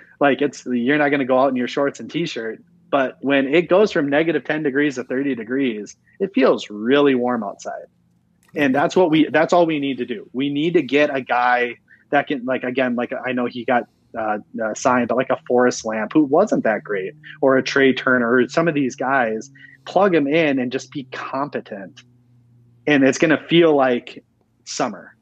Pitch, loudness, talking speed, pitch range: 135 Hz, -19 LUFS, 210 wpm, 125-150 Hz